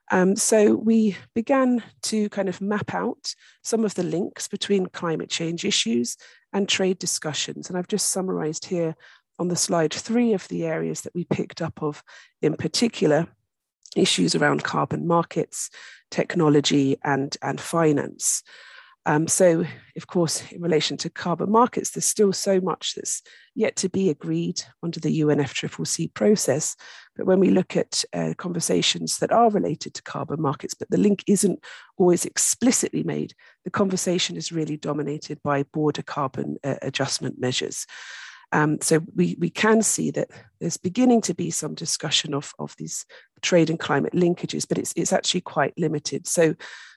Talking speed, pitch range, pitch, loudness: 160 wpm, 155-200 Hz, 175 Hz, -23 LUFS